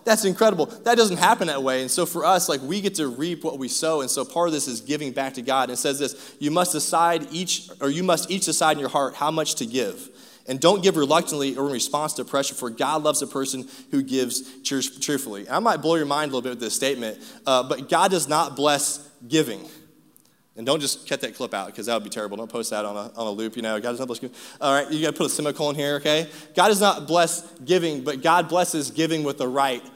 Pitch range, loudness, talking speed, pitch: 130-165 Hz, -23 LUFS, 265 wpm, 145 Hz